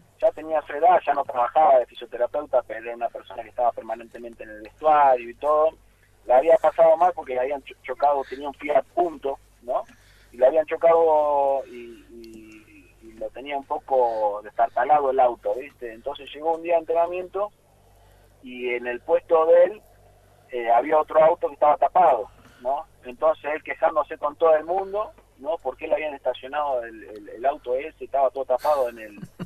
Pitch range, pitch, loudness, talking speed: 120-160 Hz, 140 Hz, -22 LUFS, 185 wpm